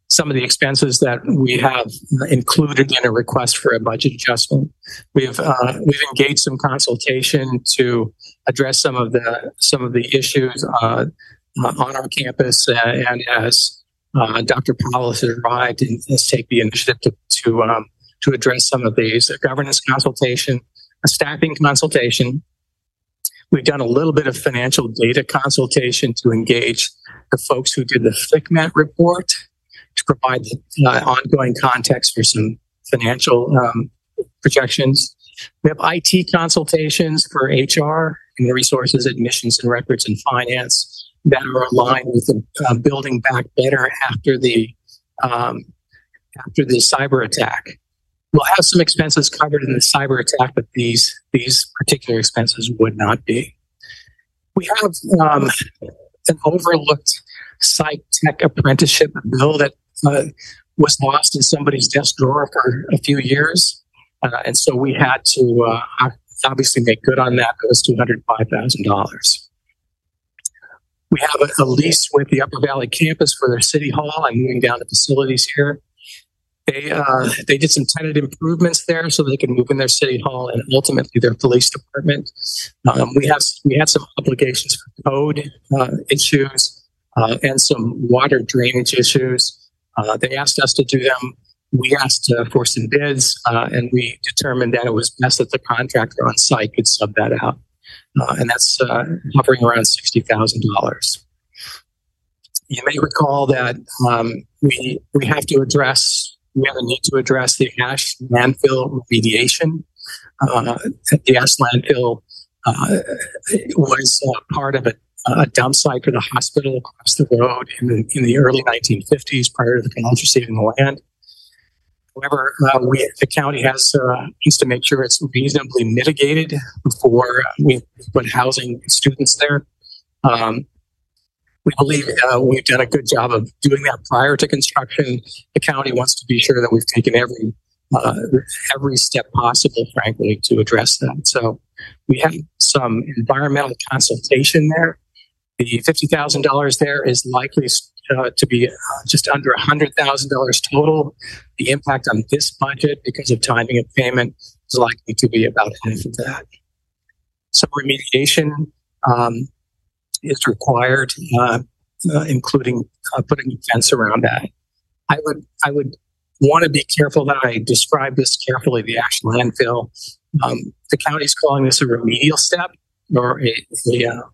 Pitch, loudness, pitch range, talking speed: 130 Hz, -16 LUFS, 120-145 Hz, 160 wpm